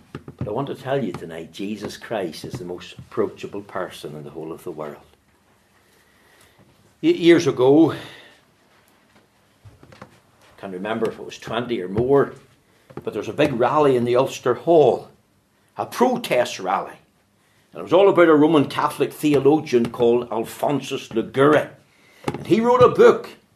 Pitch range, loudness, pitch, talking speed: 105-155 Hz, -19 LUFS, 120 Hz, 160 wpm